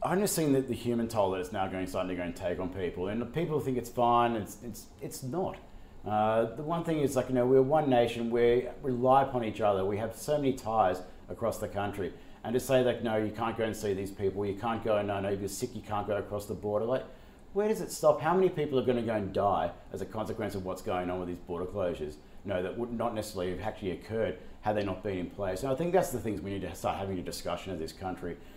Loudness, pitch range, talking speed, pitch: -31 LUFS, 95-125 Hz, 280 wpm, 110 Hz